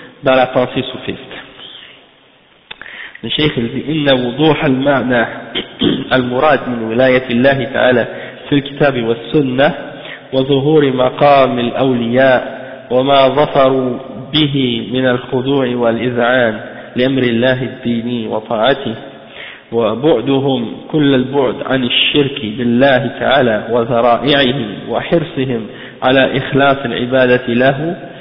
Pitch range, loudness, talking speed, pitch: 120-140 Hz, -13 LUFS, 85 wpm, 130 Hz